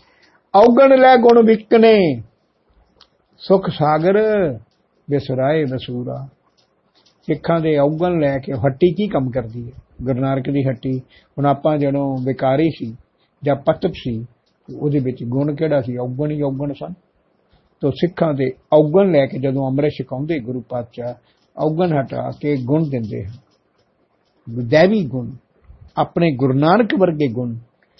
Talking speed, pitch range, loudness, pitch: 130 wpm, 130-165 Hz, -17 LUFS, 140 Hz